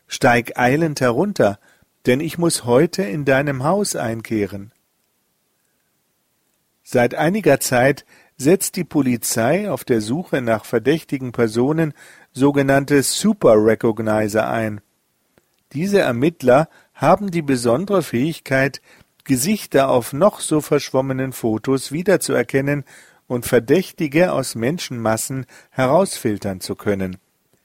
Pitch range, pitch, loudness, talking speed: 115-160 Hz, 135 Hz, -18 LUFS, 100 wpm